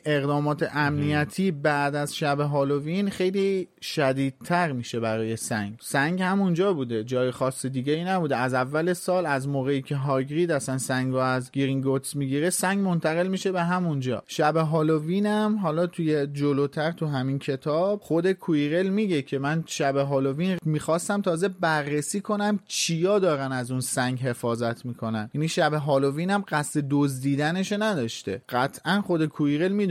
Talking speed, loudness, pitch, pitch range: 150 wpm, -25 LUFS, 150 Hz, 135-180 Hz